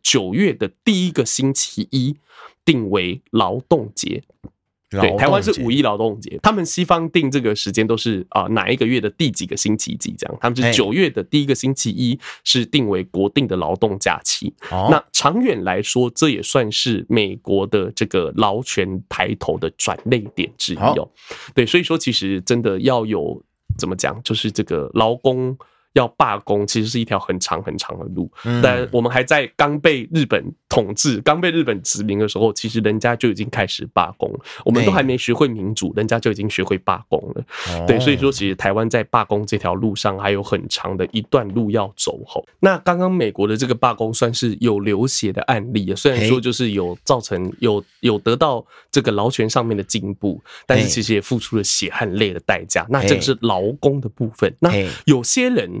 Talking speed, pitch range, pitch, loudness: 290 characters per minute, 105-135 Hz, 115 Hz, -18 LUFS